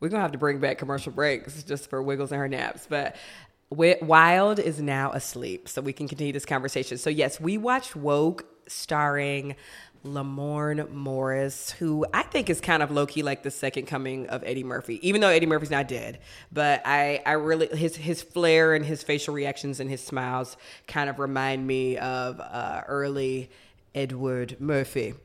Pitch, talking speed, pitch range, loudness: 140 Hz, 185 wpm, 135-155 Hz, -26 LUFS